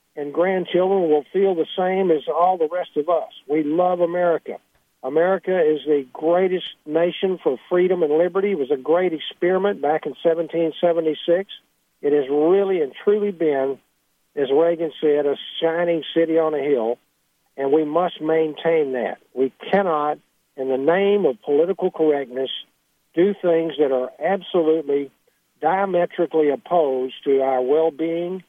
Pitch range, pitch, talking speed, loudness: 150-185 Hz, 165 Hz, 150 wpm, -21 LUFS